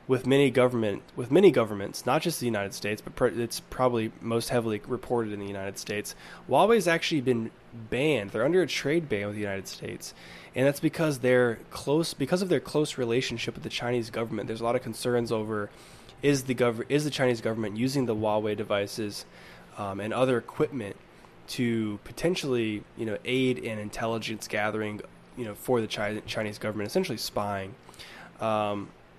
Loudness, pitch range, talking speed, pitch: -28 LUFS, 105-130 Hz, 180 wpm, 115 Hz